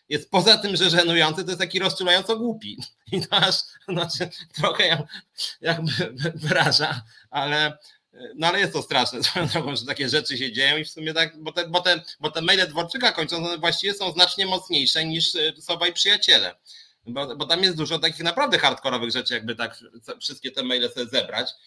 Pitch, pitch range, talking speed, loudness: 170 Hz, 150-185 Hz, 180 wpm, -21 LUFS